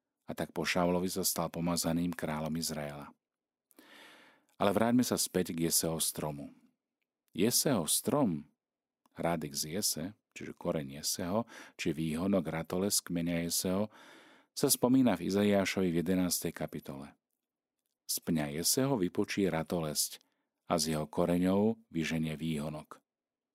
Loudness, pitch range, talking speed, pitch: -32 LUFS, 80-95 Hz, 115 wpm, 85 Hz